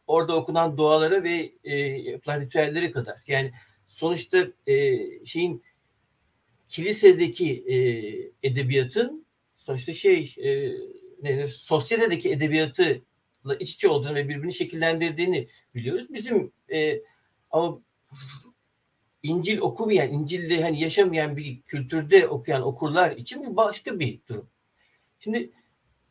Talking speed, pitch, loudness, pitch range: 100 wpm, 165 Hz, -25 LUFS, 140-230 Hz